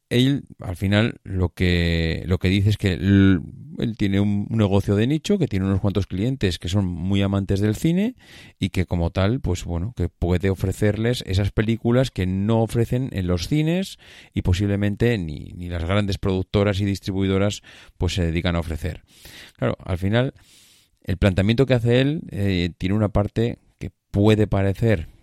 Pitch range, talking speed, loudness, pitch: 95-110 Hz, 175 wpm, -22 LUFS, 100 Hz